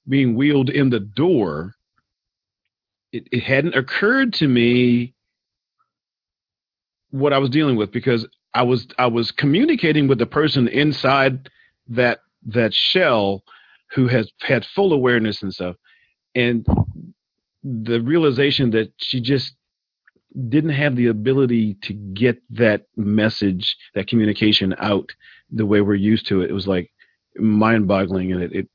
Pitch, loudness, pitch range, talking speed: 120 Hz, -19 LUFS, 105-135 Hz, 140 wpm